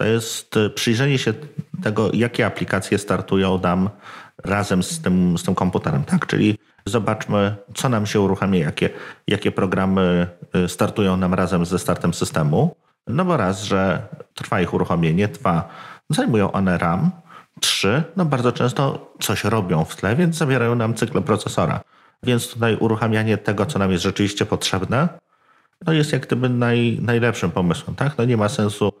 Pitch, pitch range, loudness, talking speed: 105 Hz, 95-120 Hz, -20 LUFS, 155 wpm